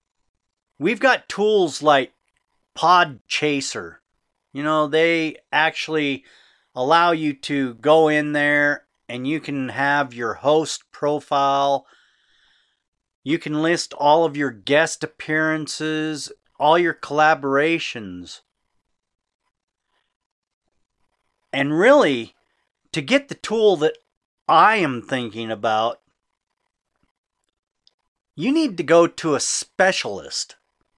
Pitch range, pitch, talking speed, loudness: 140-165 Hz, 155 Hz, 100 wpm, -20 LUFS